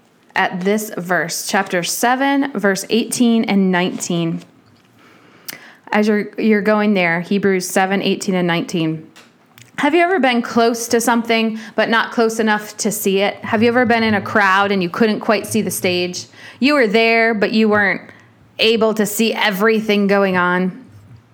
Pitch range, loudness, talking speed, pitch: 190-230 Hz, -16 LUFS, 165 wpm, 210 Hz